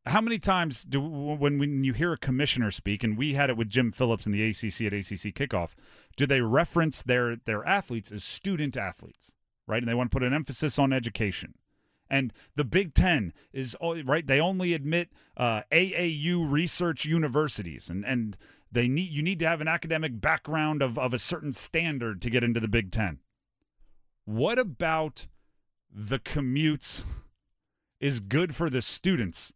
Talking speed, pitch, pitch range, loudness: 175 wpm, 135 Hz, 115-155 Hz, -28 LUFS